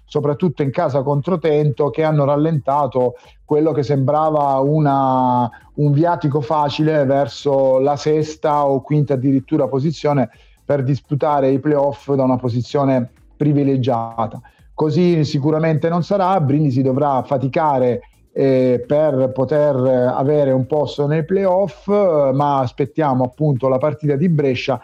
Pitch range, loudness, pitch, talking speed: 135-155 Hz, -17 LUFS, 145 Hz, 130 wpm